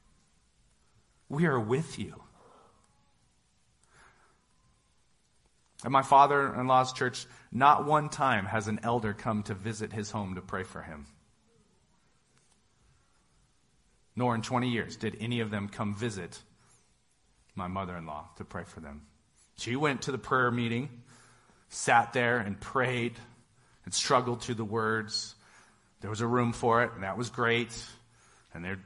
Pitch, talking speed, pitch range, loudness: 115 Hz, 145 wpm, 105-125 Hz, -30 LUFS